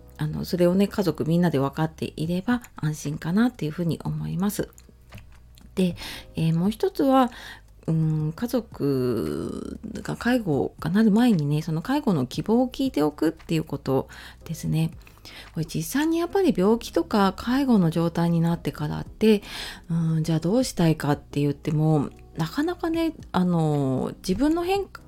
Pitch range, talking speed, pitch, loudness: 150-225 Hz, 320 characters per minute, 165 Hz, -25 LUFS